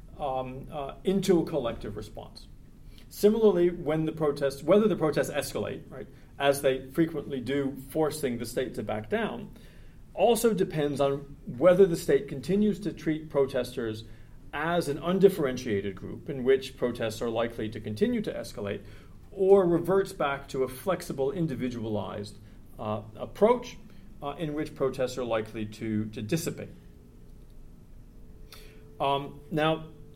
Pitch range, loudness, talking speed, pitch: 125-165 Hz, -28 LUFS, 135 wpm, 140 Hz